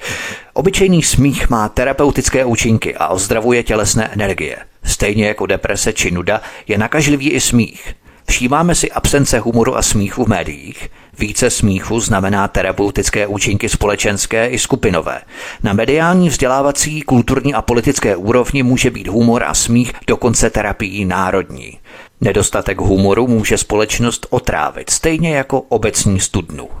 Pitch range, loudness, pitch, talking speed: 100-130 Hz, -14 LUFS, 115 Hz, 130 wpm